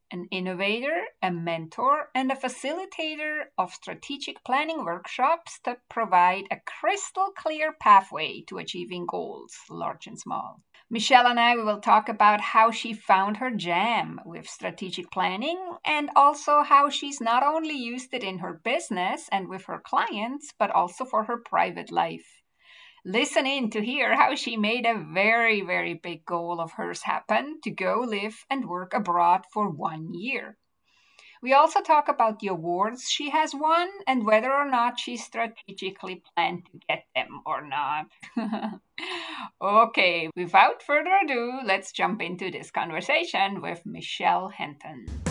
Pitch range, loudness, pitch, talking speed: 190-285 Hz, -25 LUFS, 230 Hz, 150 wpm